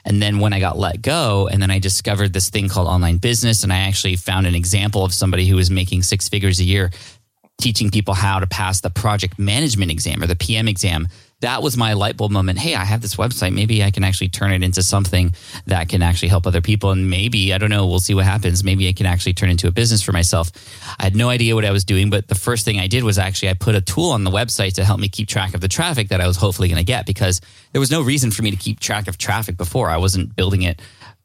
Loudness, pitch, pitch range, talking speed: -17 LUFS, 100 Hz, 95-105 Hz, 275 wpm